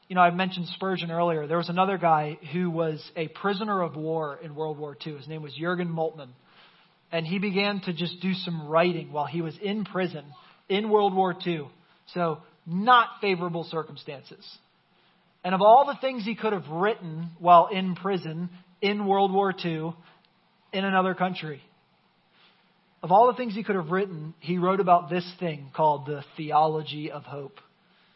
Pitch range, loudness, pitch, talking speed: 160-190 Hz, -26 LUFS, 175 Hz, 175 wpm